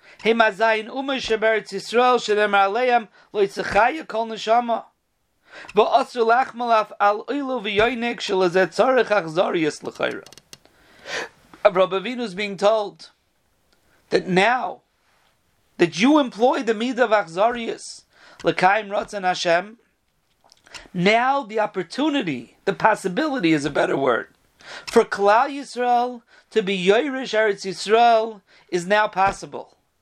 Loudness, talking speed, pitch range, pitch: -21 LUFS, 115 wpm, 195-240 Hz, 220 Hz